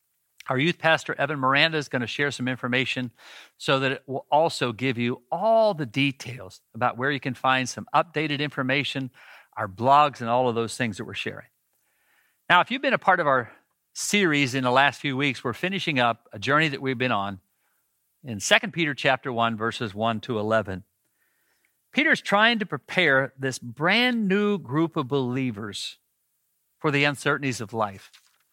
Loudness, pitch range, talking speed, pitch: -24 LUFS, 120-150 Hz, 180 wpm, 135 Hz